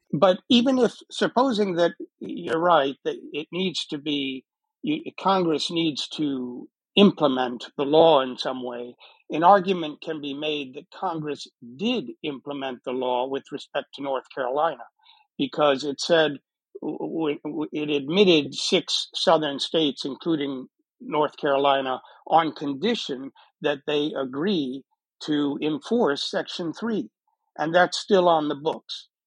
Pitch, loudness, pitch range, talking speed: 155 Hz, -24 LUFS, 140-195 Hz, 130 wpm